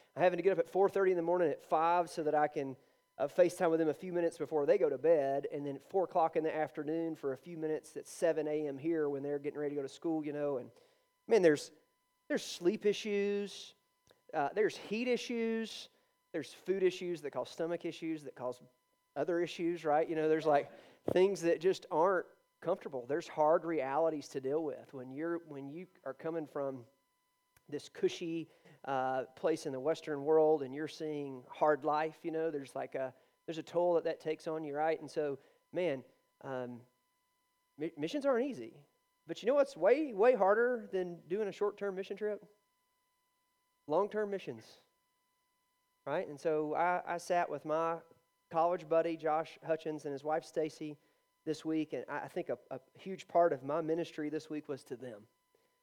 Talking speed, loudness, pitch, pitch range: 195 wpm, -35 LUFS, 165 Hz, 150-210 Hz